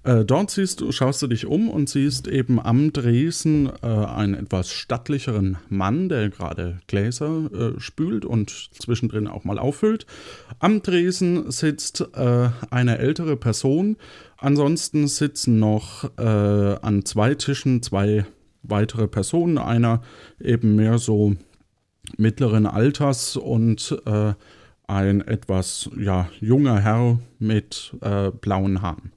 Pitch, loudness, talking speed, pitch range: 115 Hz, -22 LUFS, 130 wpm, 105-140 Hz